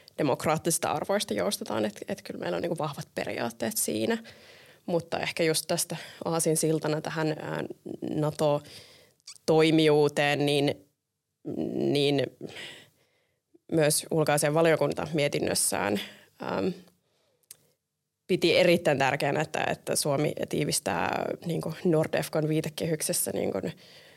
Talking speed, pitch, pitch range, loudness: 95 wpm, 155 Hz, 145-165 Hz, -27 LUFS